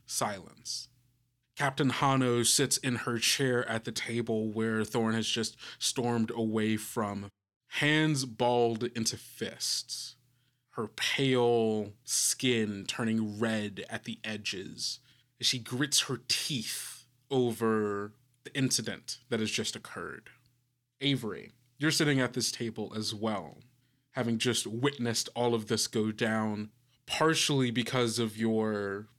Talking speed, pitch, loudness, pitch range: 125 wpm, 120 Hz, -31 LUFS, 110-125 Hz